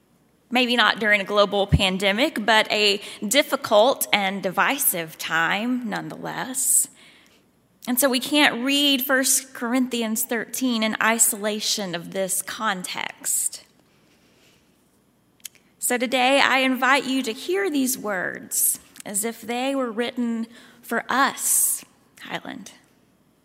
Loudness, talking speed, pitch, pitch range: -21 LUFS, 110 wpm, 235 Hz, 210-260 Hz